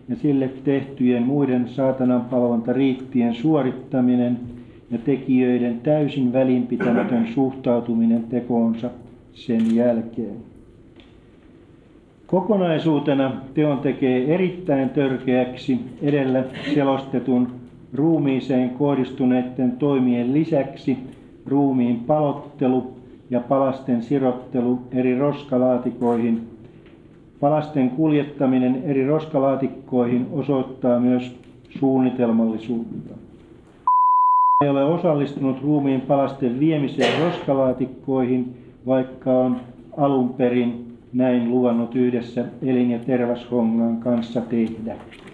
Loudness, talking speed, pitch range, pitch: -21 LUFS, 75 wpm, 125-140 Hz, 130 Hz